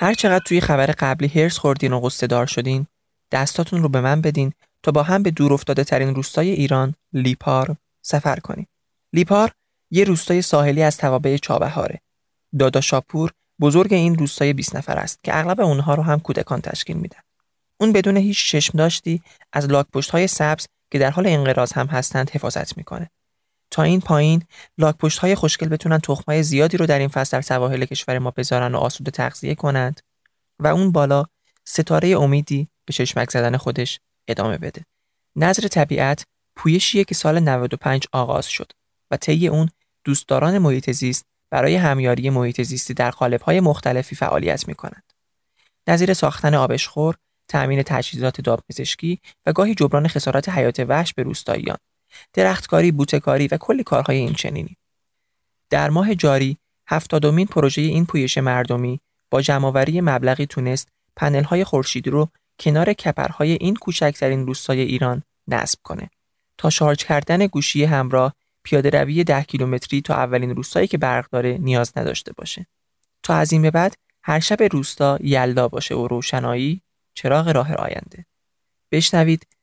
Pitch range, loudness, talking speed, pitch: 130-160 Hz, -19 LUFS, 155 wpm, 145 Hz